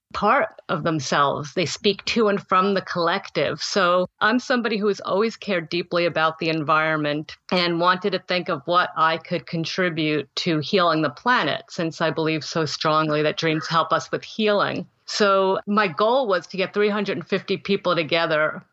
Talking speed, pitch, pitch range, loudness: 175 wpm, 175 Hz, 160-195 Hz, -22 LUFS